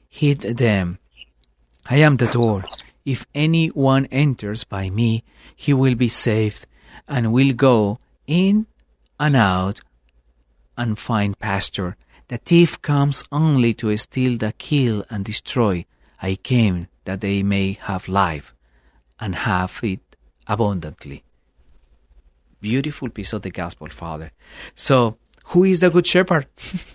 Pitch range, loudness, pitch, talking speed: 90-135 Hz, -19 LUFS, 110 Hz, 130 wpm